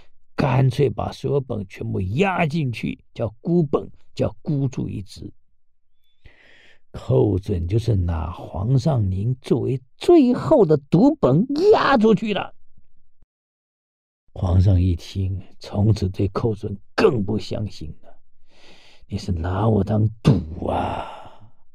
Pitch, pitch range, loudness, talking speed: 105 Hz, 95-135 Hz, -21 LUFS, 165 characters per minute